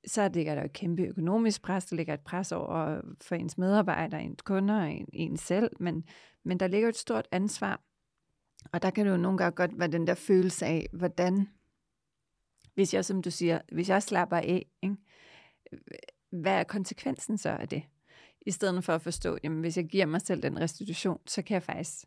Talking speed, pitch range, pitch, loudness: 210 wpm, 165-195 Hz, 180 Hz, -31 LUFS